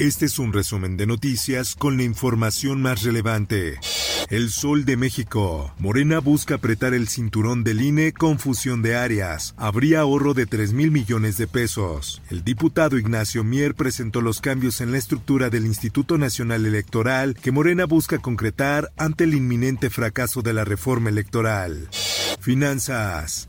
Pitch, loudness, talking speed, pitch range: 120 Hz, -21 LUFS, 155 wpm, 110-140 Hz